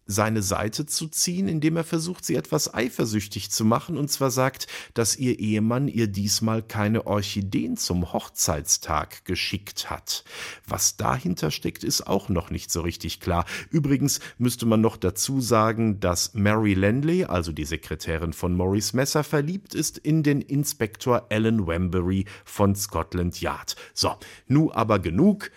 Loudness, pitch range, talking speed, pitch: -25 LUFS, 95-140 Hz, 155 wpm, 110 Hz